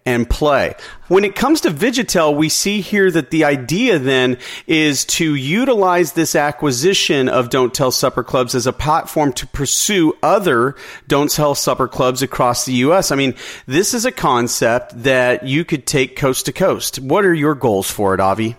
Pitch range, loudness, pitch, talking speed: 125-165 Hz, -15 LUFS, 140 Hz, 185 wpm